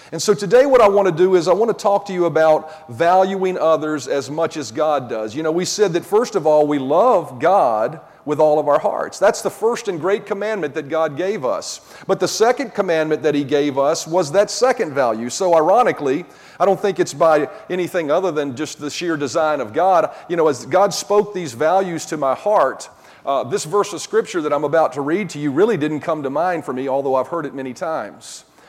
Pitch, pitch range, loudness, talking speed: 165 Hz, 150-200 Hz, -18 LUFS, 235 wpm